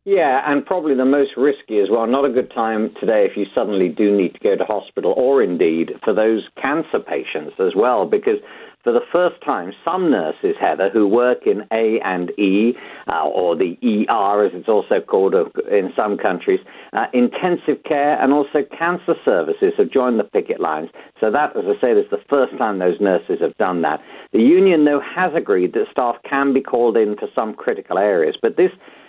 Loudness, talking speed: -18 LUFS, 200 wpm